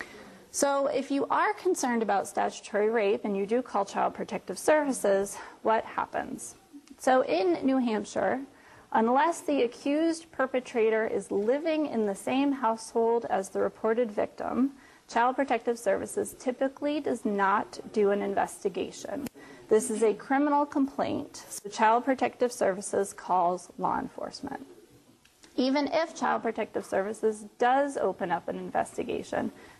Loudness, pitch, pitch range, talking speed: -29 LUFS, 245 Hz, 215-280 Hz, 135 wpm